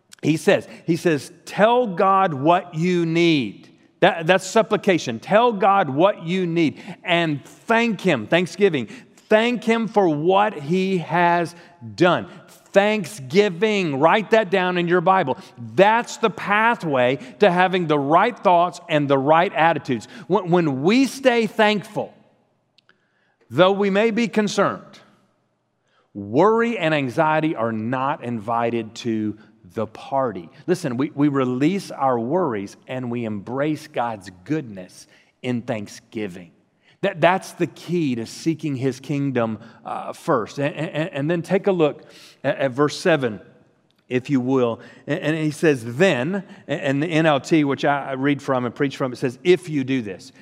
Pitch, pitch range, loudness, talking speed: 160 Hz, 135-190 Hz, -20 LUFS, 150 wpm